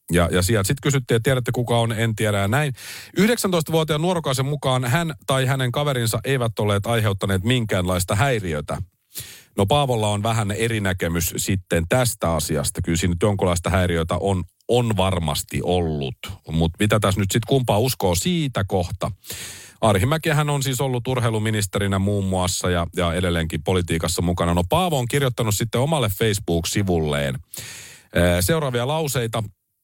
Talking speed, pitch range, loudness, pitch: 150 wpm, 90-130 Hz, -21 LUFS, 105 Hz